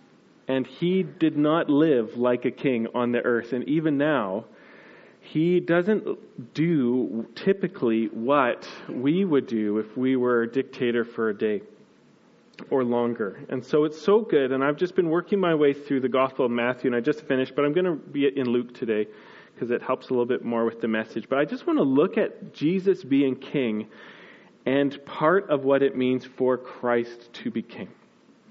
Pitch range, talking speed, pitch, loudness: 120-160 Hz, 195 wpm, 135 Hz, -25 LUFS